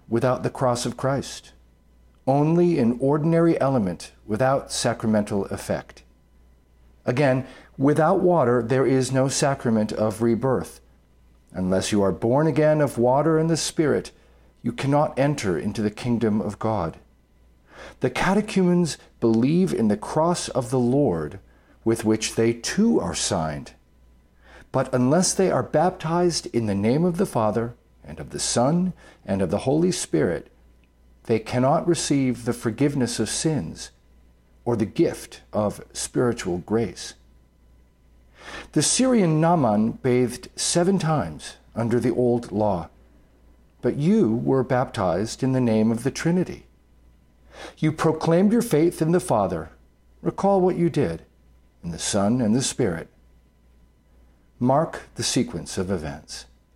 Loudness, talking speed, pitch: -23 LUFS, 135 wpm, 115 Hz